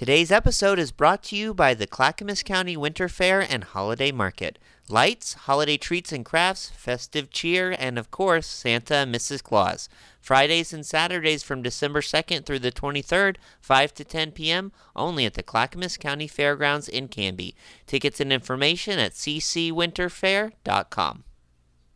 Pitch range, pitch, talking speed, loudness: 130-175 Hz, 150 Hz, 150 wpm, -24 LUFS